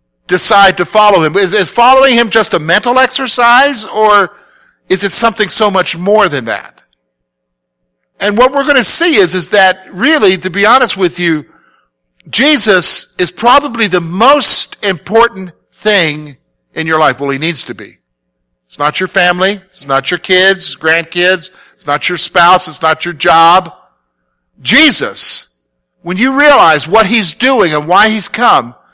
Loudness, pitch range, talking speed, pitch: -8 LUFS, 160-220 Hz, 165 wpm, 185 Hz